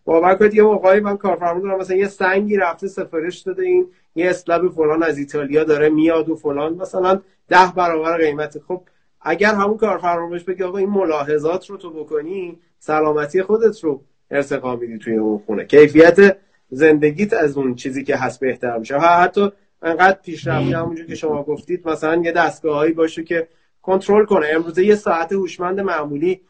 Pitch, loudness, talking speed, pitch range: 170 Hz, -17 LUFS, 170 wpm, 155-190 Hz